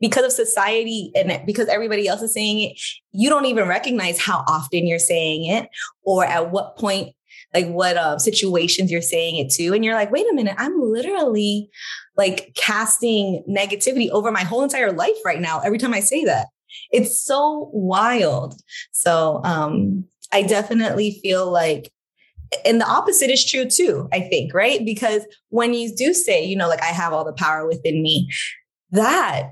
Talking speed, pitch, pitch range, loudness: 180 wpm, 205 Hz, 175-230 Hz, -19 LUFS